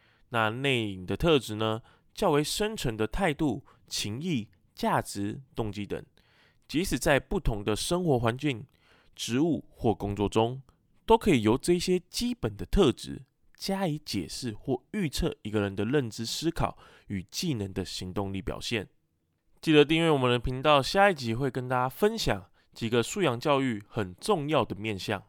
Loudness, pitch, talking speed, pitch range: -29 LUFS, 120 Hz, 240 characters per minute, 105-150 Hz